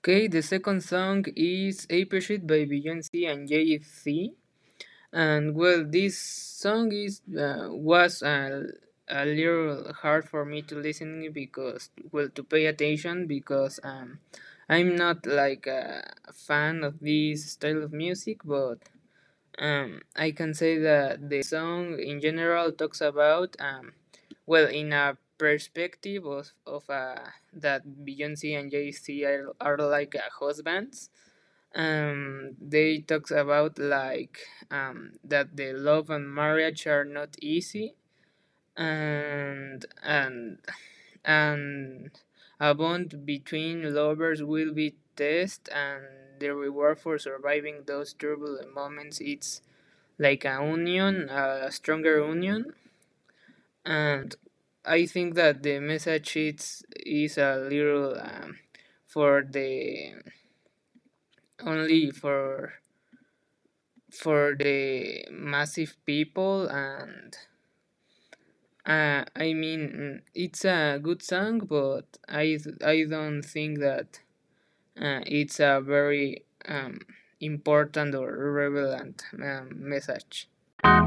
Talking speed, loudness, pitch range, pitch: 115 wpm, -28 LUFS, 145-165 Hz, 150 Hz